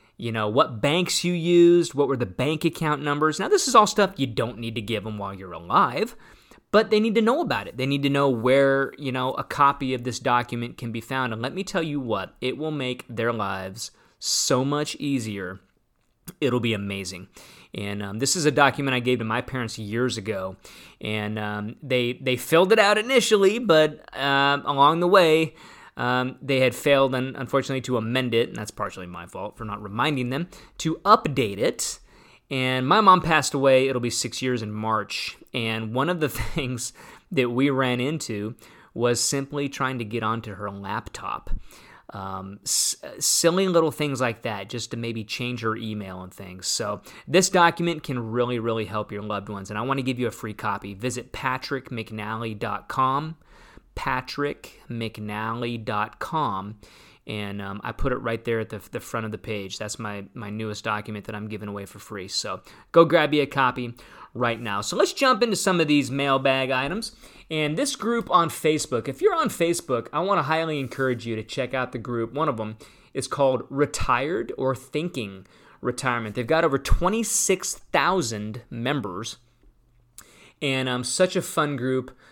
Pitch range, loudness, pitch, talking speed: 110-145 Hz, -24 LUFS, 125 Hz, 190 wpm